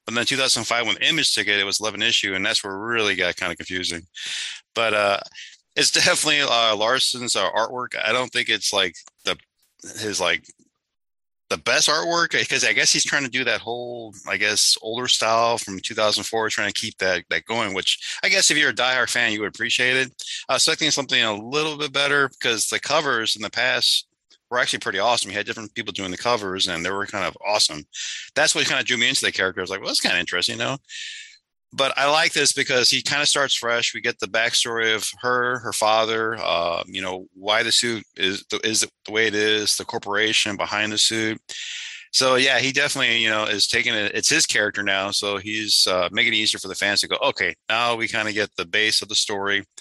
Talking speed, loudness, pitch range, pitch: 235 wpm, -20 LUFS, 105-125 Hz, 110 Hz